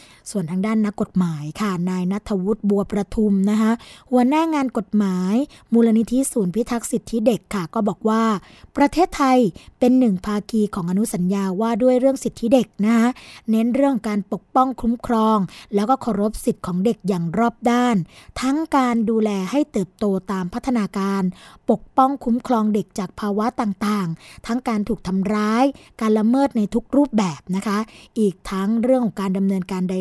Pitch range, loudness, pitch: 200-240 Hz, -20 LUFS, 220 Hz